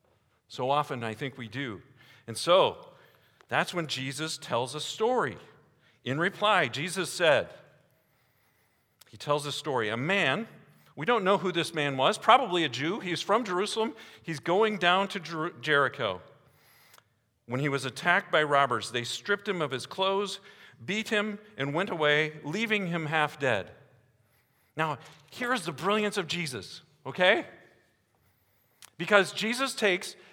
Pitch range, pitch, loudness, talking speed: 130-185 Hz, 155 Hz, -28 LUFS, 150 wpm